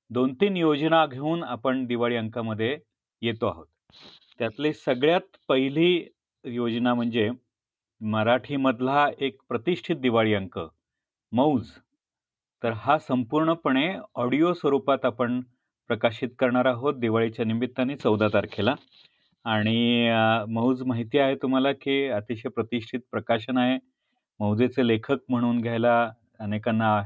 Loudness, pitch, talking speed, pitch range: -25 LUFS, 125 Hz, 105 wpm, 115-135 Hz